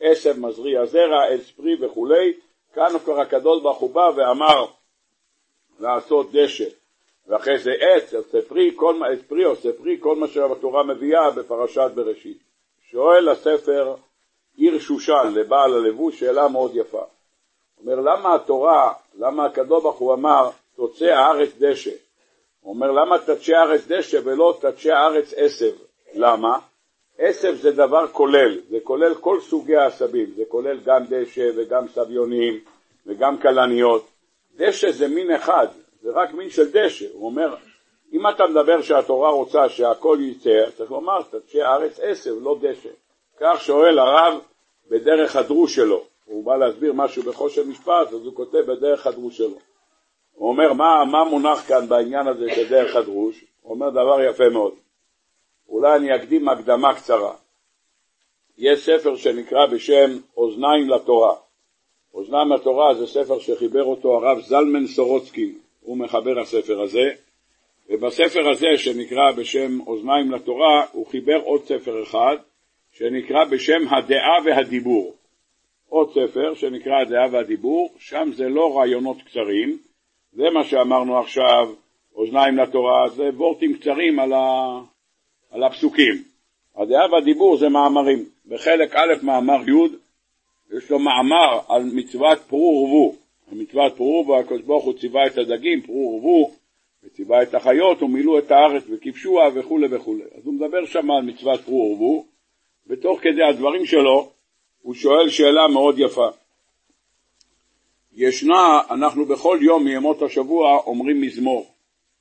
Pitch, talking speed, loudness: 175 Hz, 140 wpm, -18 LUFS